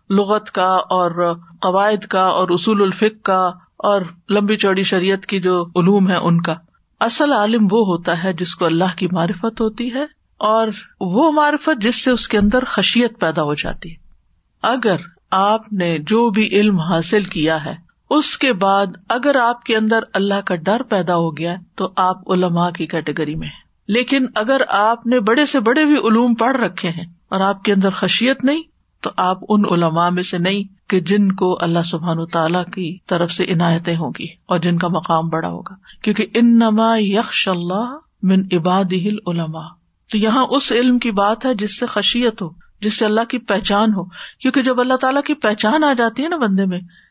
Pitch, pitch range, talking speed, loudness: 195 Hz, 180-225 Hz, 195 wpm, -17 LUFS